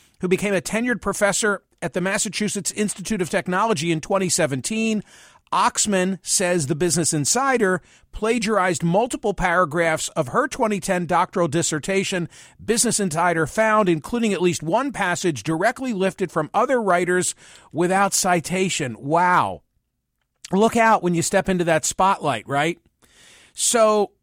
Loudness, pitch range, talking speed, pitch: -21 LUFS, 170-210 Hz, 130 wpm, 185 Hz